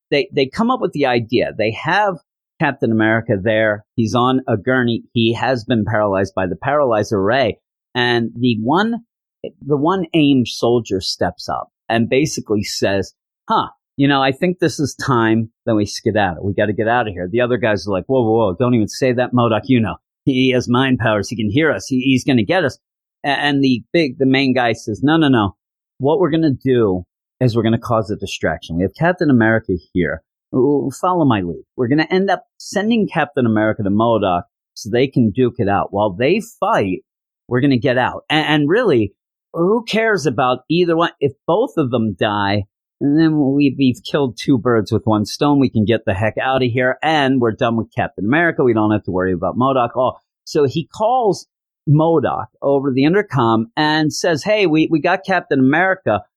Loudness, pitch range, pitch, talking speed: -17 LUFS, 110-145 Hz, 125 Hz, 215 wpm